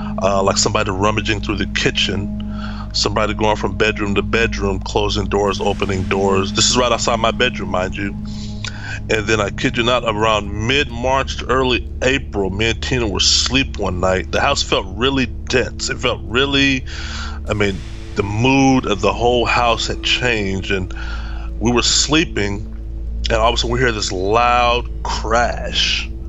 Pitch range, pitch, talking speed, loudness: 95-110 Hz, 105 Hz, 170 wpm, -17 LUFS